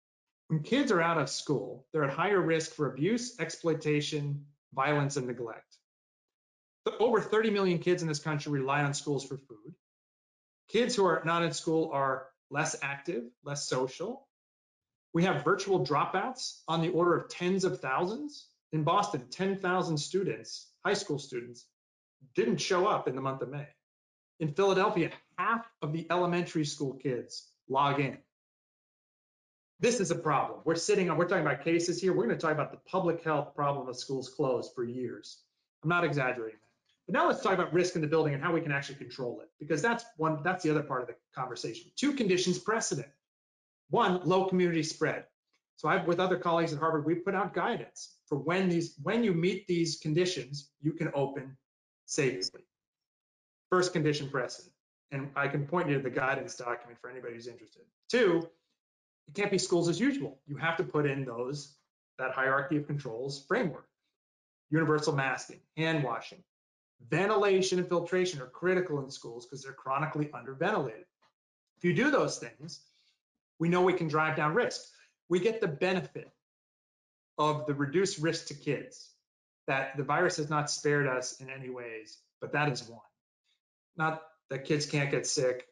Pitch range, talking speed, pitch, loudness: 140-180 Hz, 175 wpm, 155 Hz, -31 LUFS